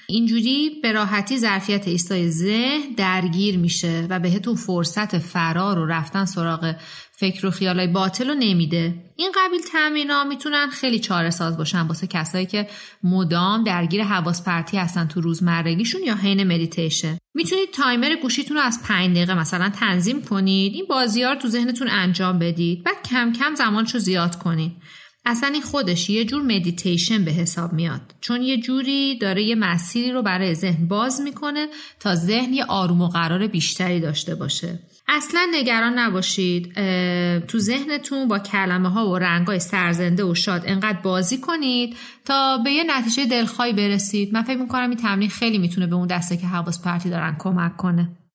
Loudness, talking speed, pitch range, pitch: -21 LUFS, 165 wpm, 175-245 Hz, 195 Hz